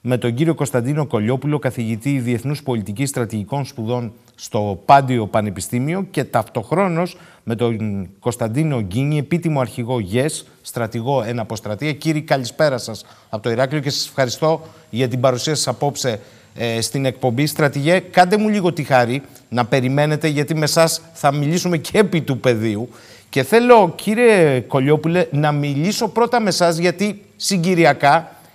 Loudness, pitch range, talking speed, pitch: -18 LUFS, 120-160 Hz, 145 wpm, 140 Hz